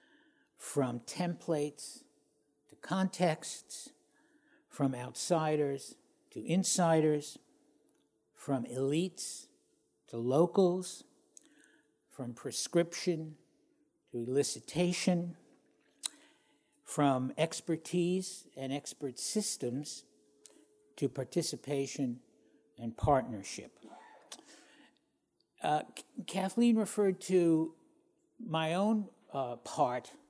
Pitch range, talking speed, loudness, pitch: 140-200 Hz, 65 wpm, -34 LUFS, 165 Hz